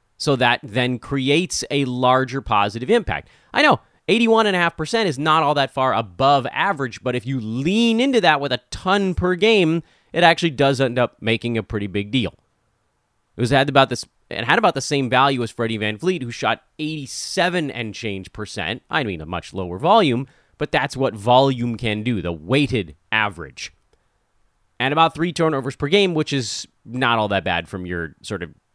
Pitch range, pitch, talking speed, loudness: 115-155 Hz, 130 Hz, 190 wpm, -20 LUFS